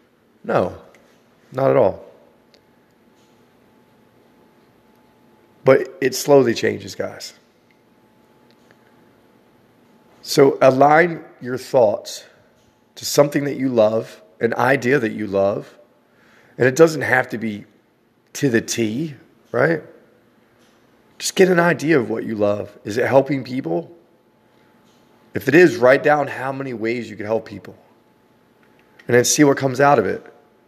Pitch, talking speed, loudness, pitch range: 125 Hz, 125 wpm, -18 LUFS, 110-140 Hz